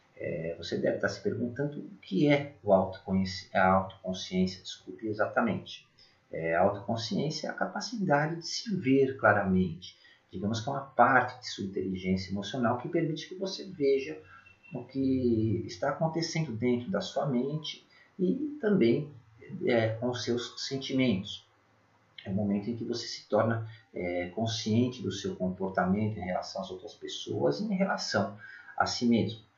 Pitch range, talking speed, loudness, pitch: 100-140 Hz, 150 wpm, -30 LUFS, 120 Hz